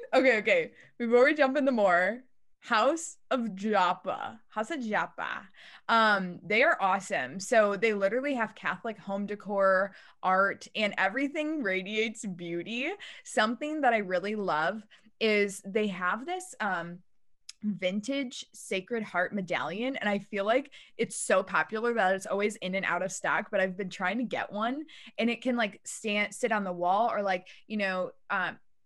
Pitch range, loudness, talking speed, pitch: 190-240 Hz, -29 LUFS, 165 wpm, 210 Hz